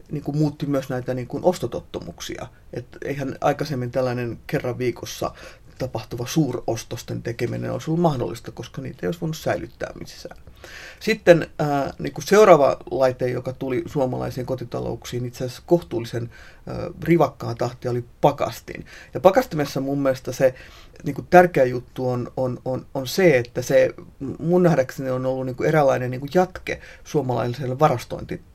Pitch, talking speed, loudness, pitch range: 130 Hz, 155 wpm, -22 LUFS, 120-155 Hz